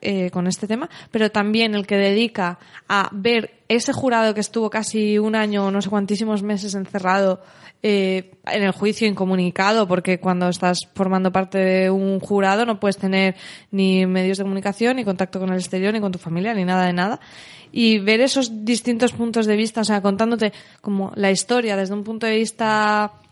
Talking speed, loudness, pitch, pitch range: 190 wpm, -20 LUFS, 200 Hz, 190-220 Hz